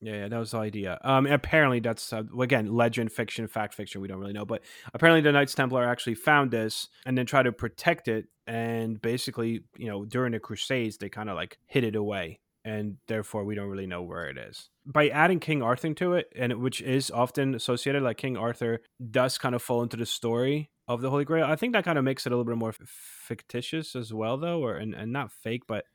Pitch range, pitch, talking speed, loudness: 110-135 Hz, 120 Hz, 240 wpm, -28 LUFS